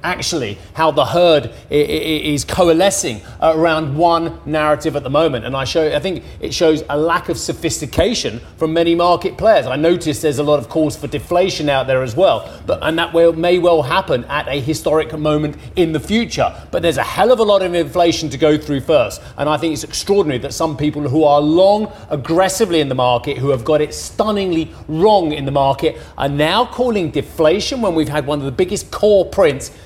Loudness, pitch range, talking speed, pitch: -16 LUFS, 145-175 Hz, 205 wpm, 155 Hz